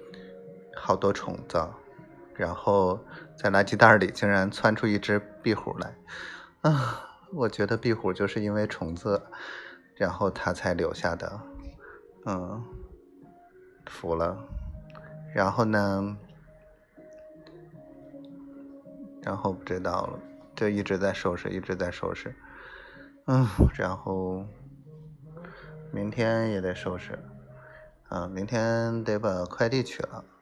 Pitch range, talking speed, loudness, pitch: 95-155 Hz, 160 characters per minute, -28 LUFS, 105 Hz